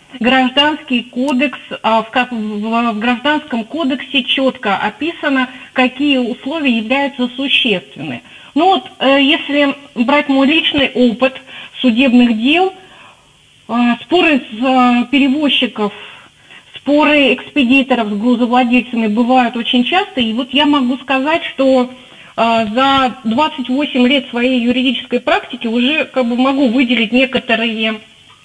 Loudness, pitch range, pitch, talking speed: -13 LUFS, 245-280 Hz, 255 Hz, 100 wpm